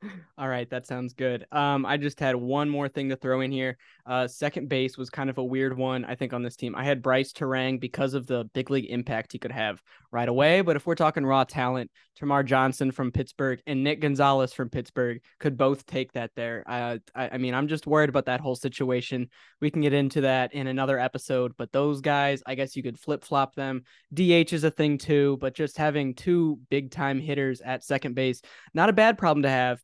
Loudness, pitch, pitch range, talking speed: -27 LUFS, 135 Hz, 125-145 Hz, 230 wpm